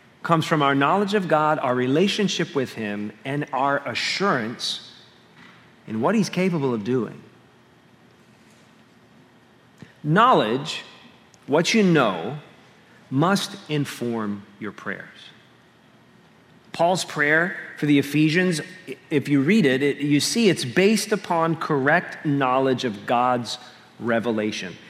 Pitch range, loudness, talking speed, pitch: 125-175 Hz, -22 LUFS, 115 wpm, 145 Hz